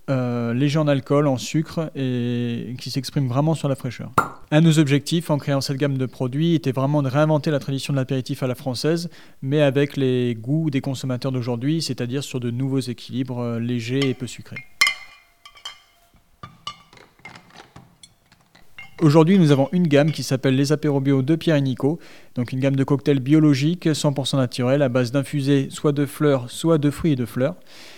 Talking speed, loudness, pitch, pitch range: 180 wpm, -21 LUFS, 140 Hz, 130-150 Hz